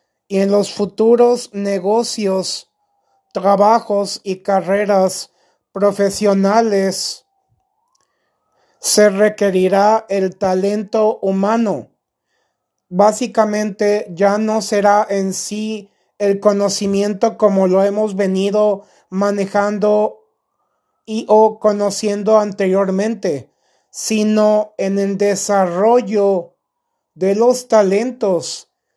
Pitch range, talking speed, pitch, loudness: 195-215 Hz, 80 wpm, 205 Hz, -16 LUFS